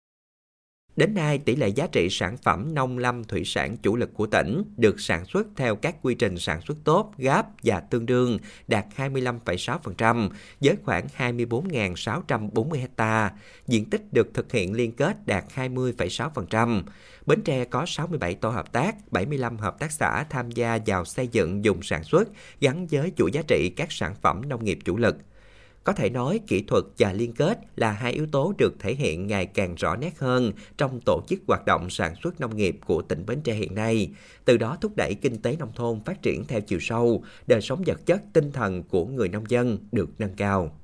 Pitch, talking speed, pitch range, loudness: 120 Hz, 200 wpm, 110-135 Hz, -26 LUFS